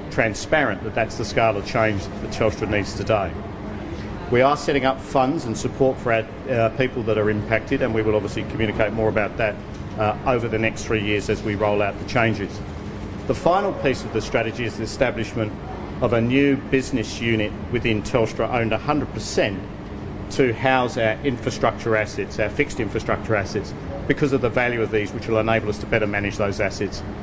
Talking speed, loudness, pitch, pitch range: 190 wpm, -22 LUFS, 110 Hz, 105-120 Hz